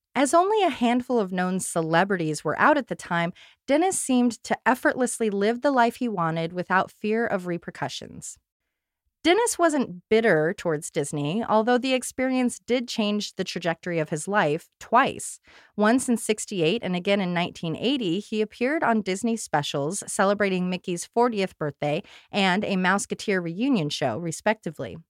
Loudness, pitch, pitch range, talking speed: -24 LUFS, 205 Hz, 170-235 Hz, 150 wpm